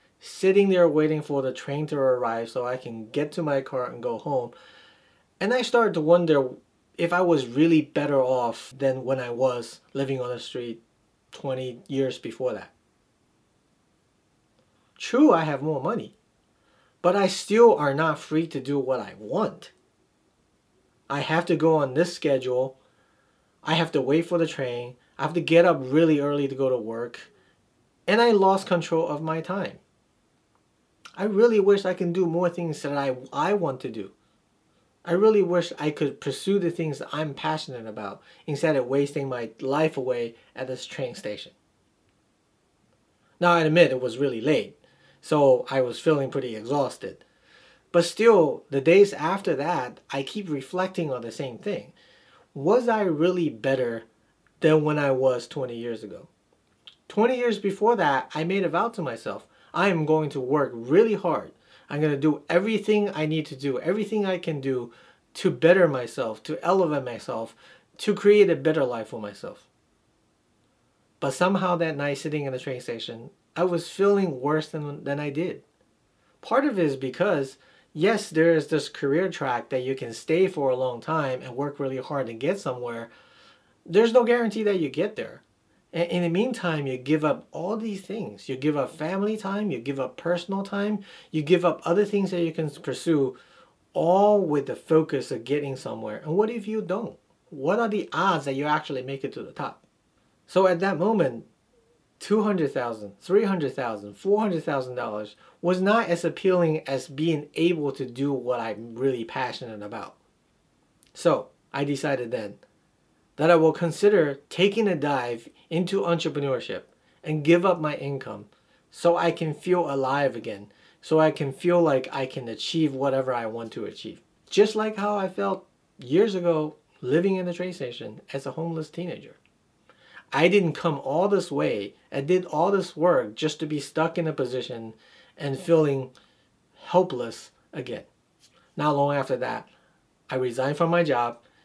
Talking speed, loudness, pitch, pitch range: 175 wpm, -25 LUFS, 155 Hz, 135-180 Hz